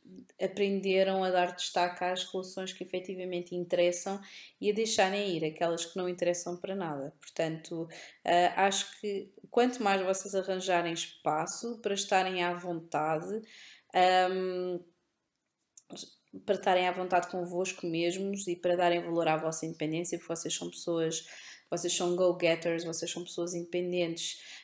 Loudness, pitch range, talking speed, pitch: -31 LUFS, 170-190 Hz, 140 wpm, 180 Hz